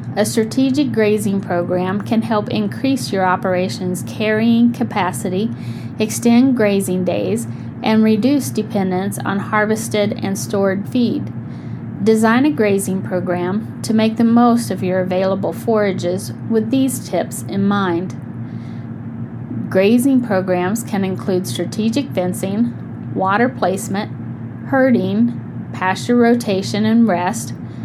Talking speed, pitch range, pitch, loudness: 110 wpm, 185-230 Hz, 205 Hz, -17 LUFS